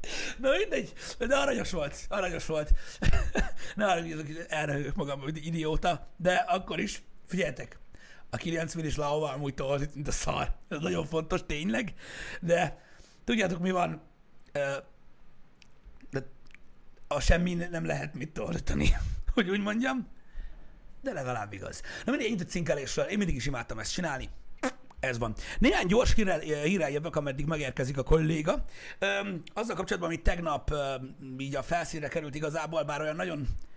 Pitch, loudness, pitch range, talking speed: 160 Hz, -31 LUFS, 140-180 Hz, 145 wpm